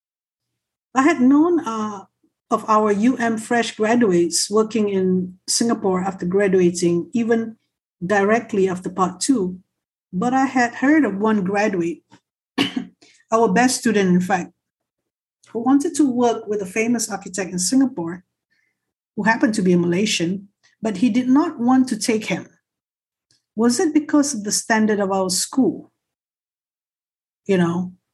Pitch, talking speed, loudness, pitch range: 220 Hz, 140 wpm, -19 LUFS, 190-245 Hz